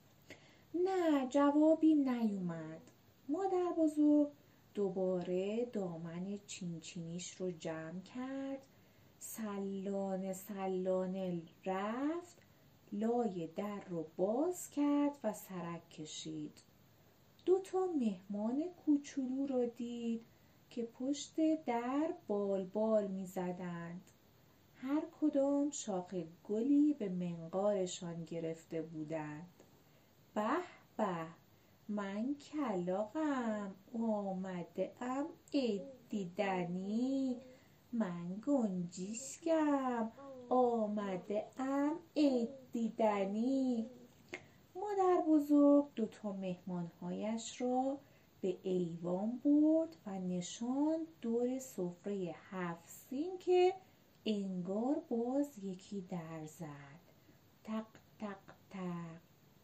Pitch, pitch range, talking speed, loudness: 210 Hz, 180-275 Hz, 80 wpm, -38 LUFS